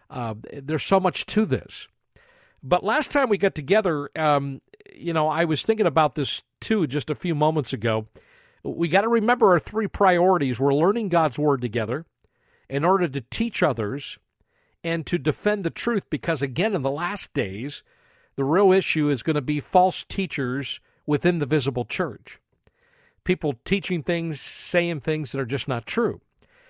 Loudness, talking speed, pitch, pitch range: -23 LUFS, 175 wpm, 160 Hz, 140-190 Hz